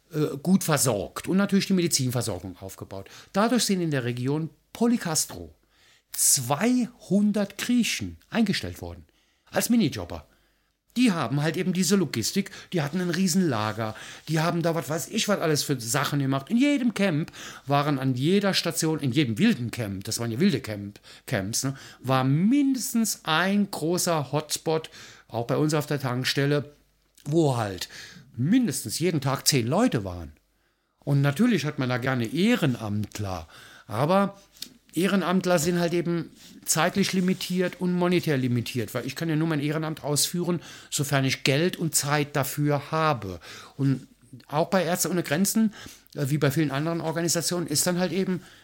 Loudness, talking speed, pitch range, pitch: -25 LUFS, 155 wpm, 130-185 Hz, 155 Hz